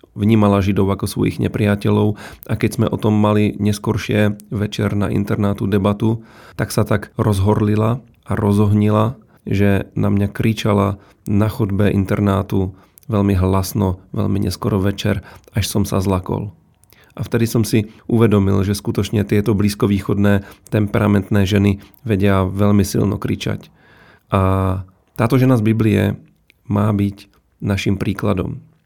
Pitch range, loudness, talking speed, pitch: 100-110 Hz, -18 LUFS, 130 wpm, 105 Hz